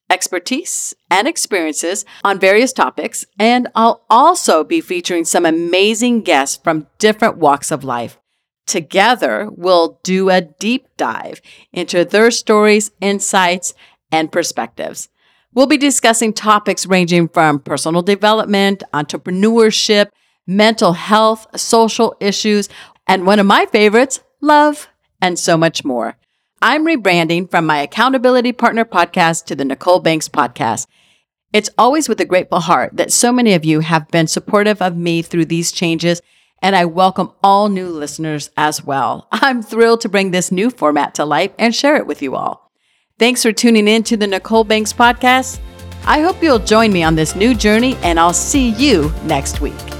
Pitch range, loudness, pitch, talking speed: 170-230 Hz, -13 LUFS, 200 Hz, 160 wpm